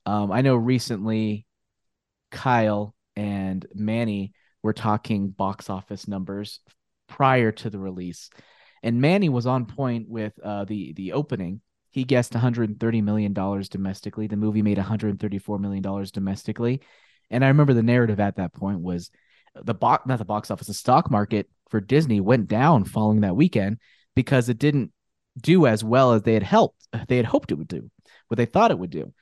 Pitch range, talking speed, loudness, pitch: 100-120 Hz, 175 wpm, -23 LUFS, 110 Hz